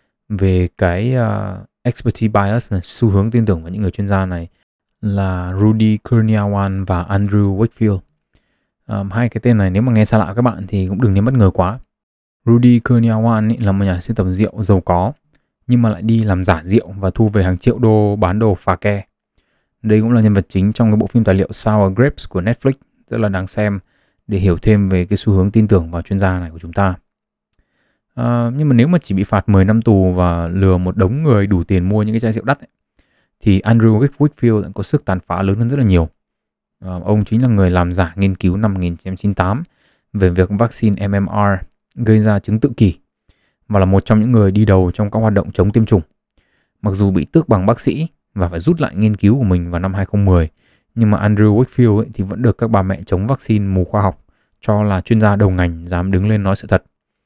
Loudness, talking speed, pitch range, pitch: -15 LUFS, 230 wpm, 95-115 Hz, 100 Hz